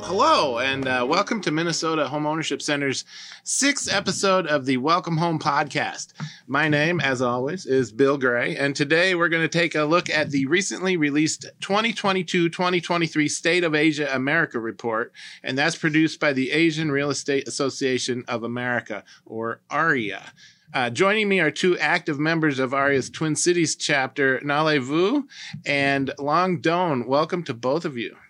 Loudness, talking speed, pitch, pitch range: -22 LUFS, 165 wpm, 150 Hz, 140-170 Hz